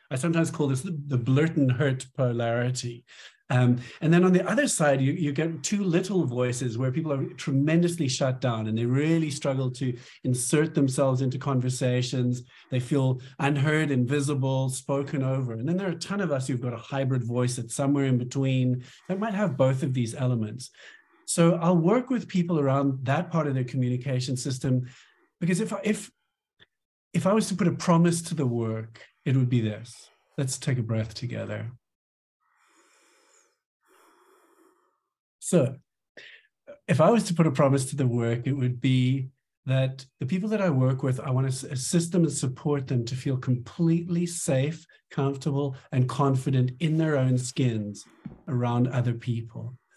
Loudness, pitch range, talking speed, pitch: -26 LUFS, 125-165 Hz, 175 wpm, 135 Hz